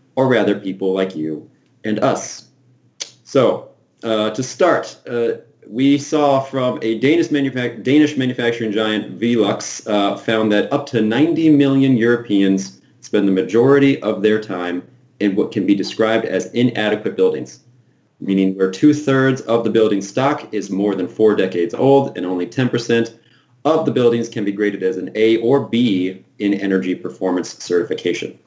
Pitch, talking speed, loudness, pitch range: 115 Hz, 160 wpm, -17 LUFS, 100-130 Hz